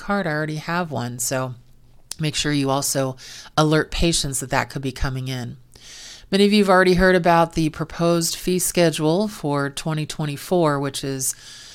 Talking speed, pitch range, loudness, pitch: 170 wpm, 135-170 Hz, -21 LUFS, 150 Hz